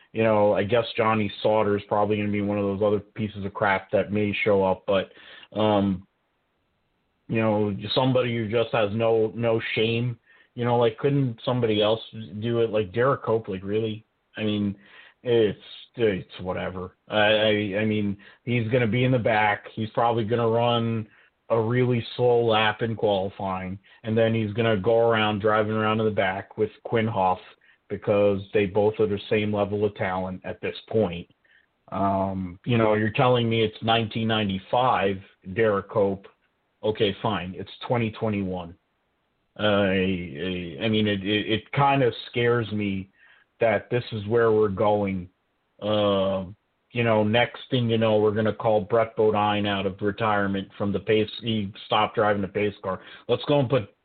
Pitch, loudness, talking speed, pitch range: 105 Hz, -24 LUFS, 175 wpm, 100-115 Hz